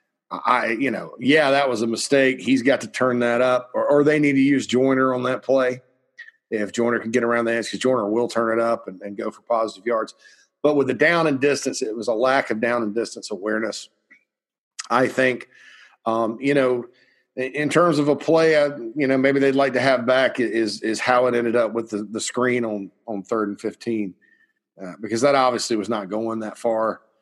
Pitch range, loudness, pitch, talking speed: 115-135 Hz, -21 LUFS, 125 Hz, 225 wpm